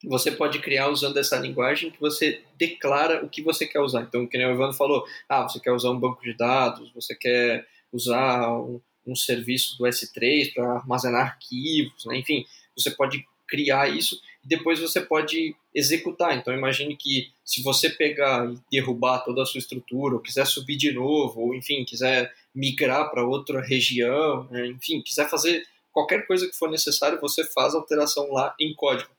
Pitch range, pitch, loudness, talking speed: 125-150 Hz, 135 Hz, -24 LUFS, 185 wpm